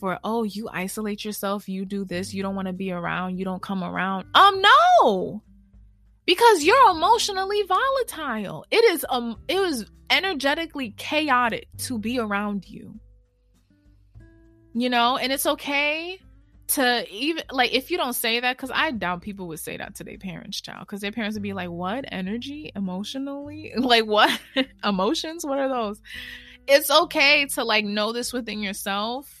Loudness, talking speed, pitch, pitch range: -22 LUFS, 165 wpm, 230 Hz, 195-285 Hz